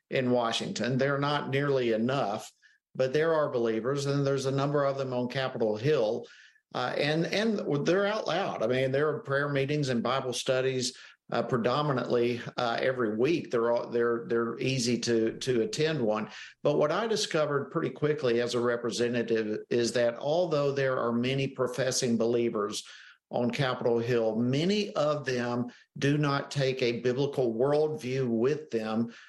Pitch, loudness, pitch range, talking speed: 130 Hz, -29 LUFS, 120-140 Hz, 160 wpm